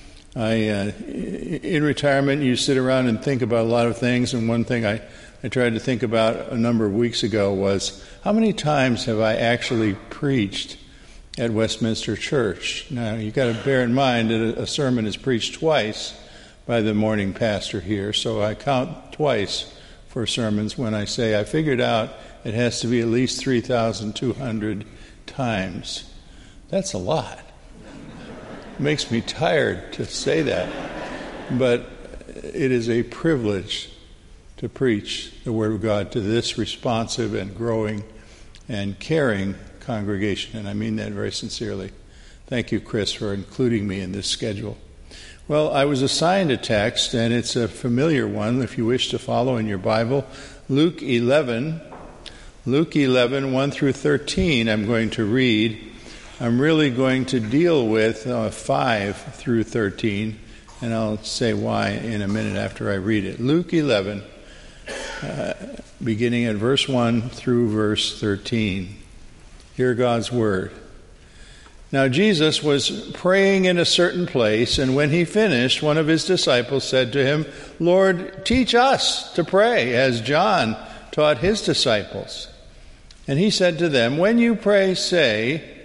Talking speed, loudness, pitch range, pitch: 155 wpm, -21 LUFS, 110-135 Hz, 115 Hz